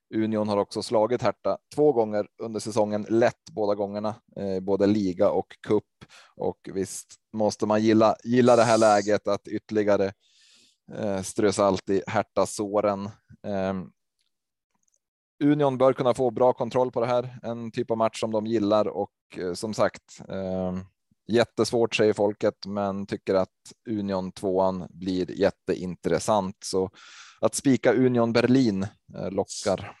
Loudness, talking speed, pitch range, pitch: -25 LUFS, 130 wpm, 100-115 Hz, 105 Hz